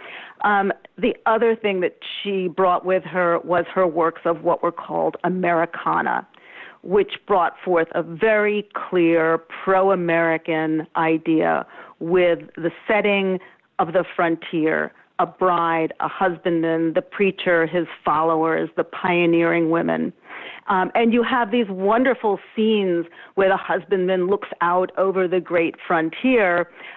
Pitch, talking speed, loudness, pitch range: 180 Hz, 130 wpm, -20 LUFS, 165-195 Hz